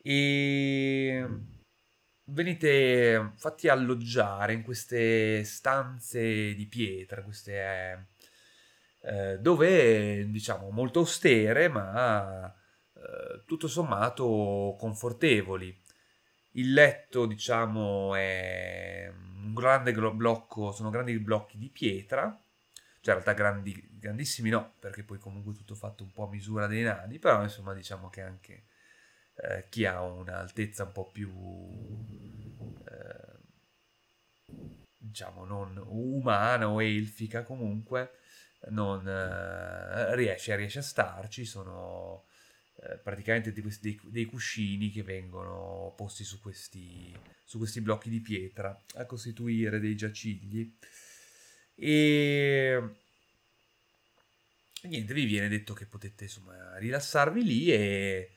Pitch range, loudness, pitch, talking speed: 100-120 Hz, -29 LUFS, 110 Hz, 110 wpm